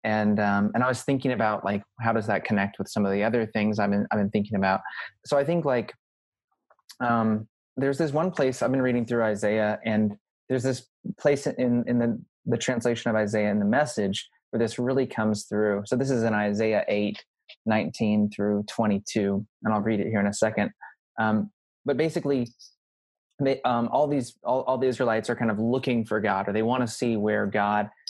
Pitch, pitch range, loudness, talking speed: 110 Hz, 105-125 Hz, -26 LUFS, 210 wpm